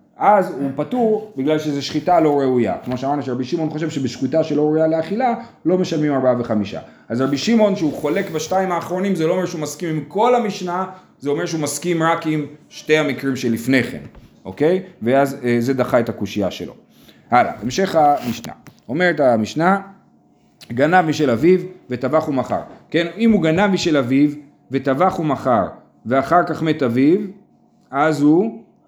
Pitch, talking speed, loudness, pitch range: 155 Hz, 165 wpm, -18 LUFS, 135-180 Hz